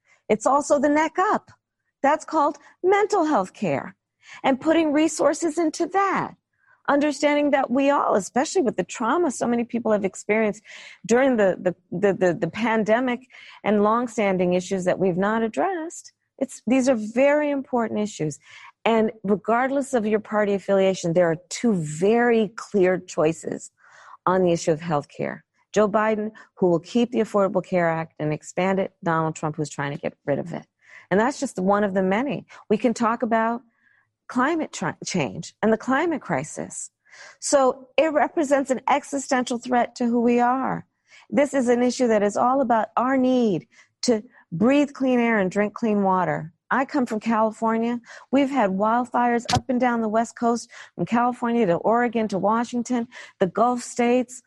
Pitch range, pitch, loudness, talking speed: 195-270 Hz, 230 Hz, -23 LUFS, 170 wpm